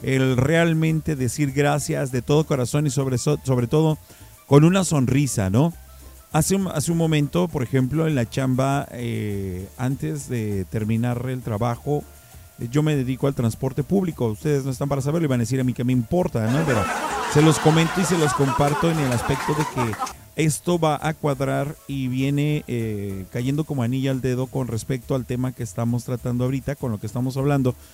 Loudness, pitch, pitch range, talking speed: -22 LUFS, 135 Hz, 125-150 Hz, 195 wpm